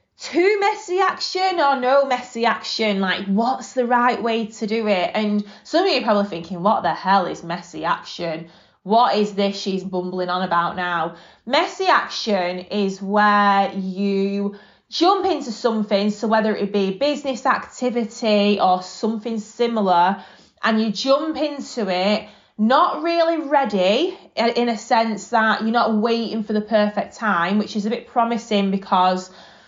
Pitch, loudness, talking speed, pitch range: 215 Hz, -20 LUFS, 160 wpm, 195-245 Hz